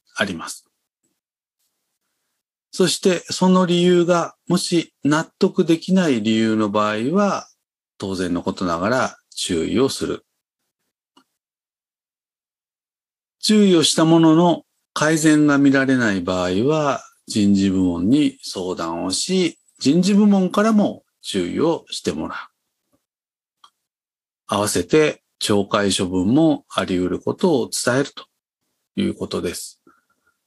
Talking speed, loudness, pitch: 215 characters per minute, -19 LUFS, 155 Hz